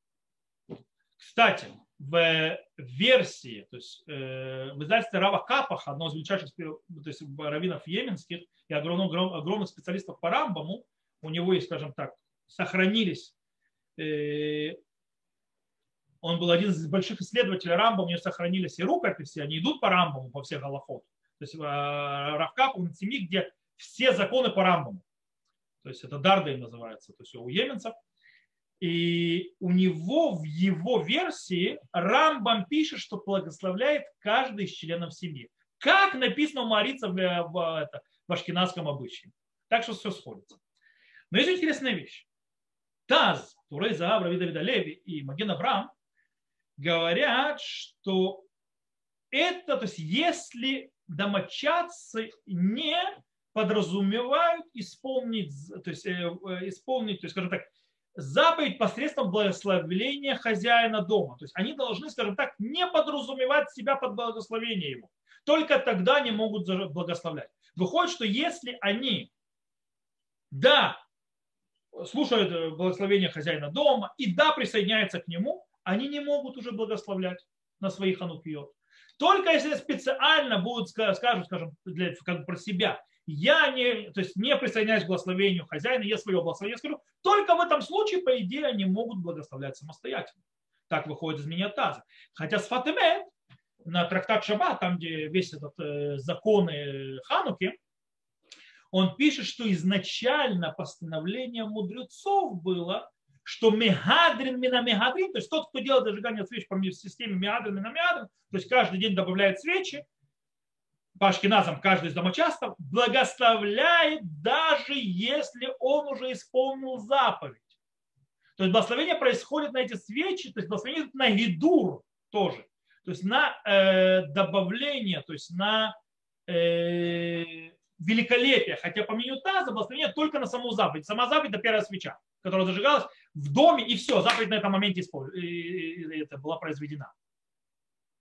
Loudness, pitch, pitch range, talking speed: -27 LUFS, 195 Hz, 170-255 Hz, 135 wpm